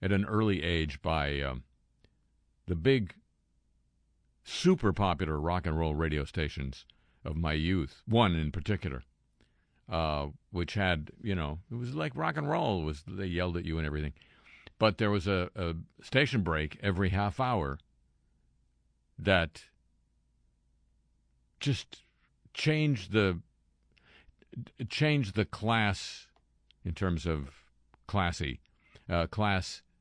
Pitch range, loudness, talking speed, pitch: 70-100 Hz, -32 LUFS, 125 wpm, 85 Hz